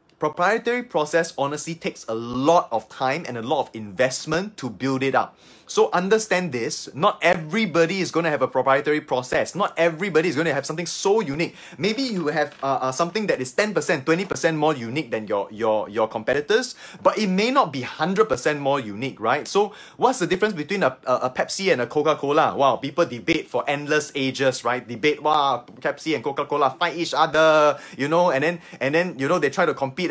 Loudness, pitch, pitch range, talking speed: -22 LUFS, 160 Hz, 135-180 Hz, 205 wpm